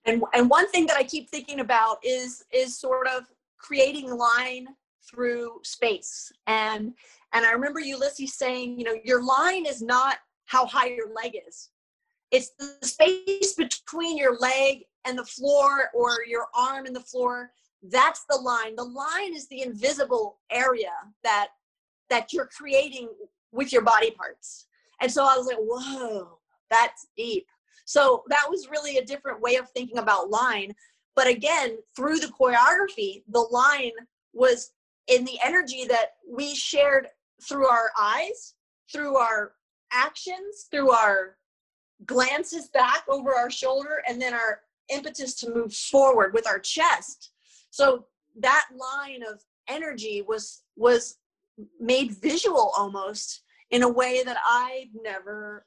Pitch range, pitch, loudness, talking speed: 240-315 Hz, 260 Hz, -24 LUFS, 150 wpm